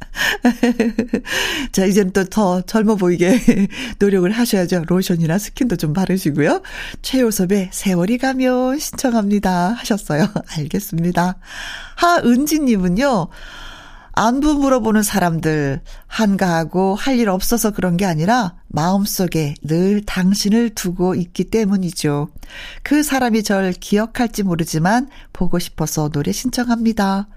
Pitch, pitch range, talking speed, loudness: 200 Hz, 180-235 Hz, 270 characters per minute, -17 LUFS